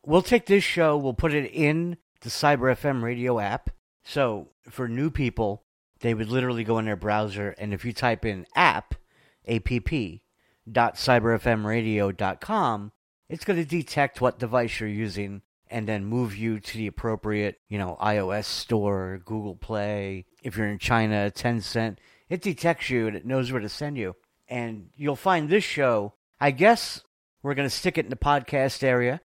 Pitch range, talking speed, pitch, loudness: 105-140 Hz, 170 wpm, 115 Hz, -26 LUFS